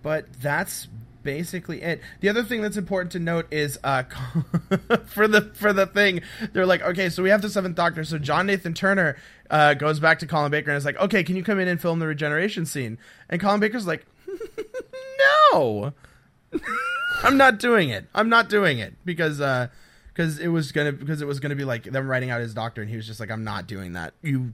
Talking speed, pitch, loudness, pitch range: 220 wpm, 165 Hz, -23 LUFS, 140-200 Hz